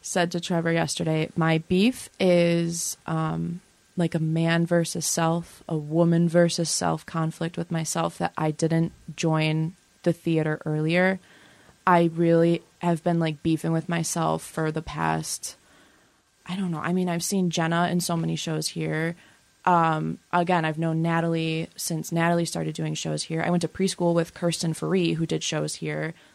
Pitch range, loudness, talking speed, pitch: 160-170 Hz, -25 LUFS, 165 wpm, 165 Hz